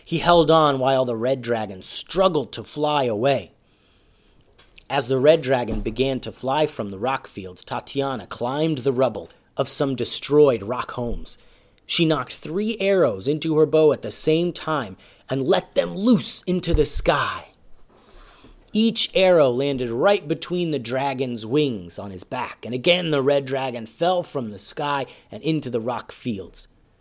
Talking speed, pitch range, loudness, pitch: 165 wpm, 125-160 Hz, -22 LUFS, 140 Hz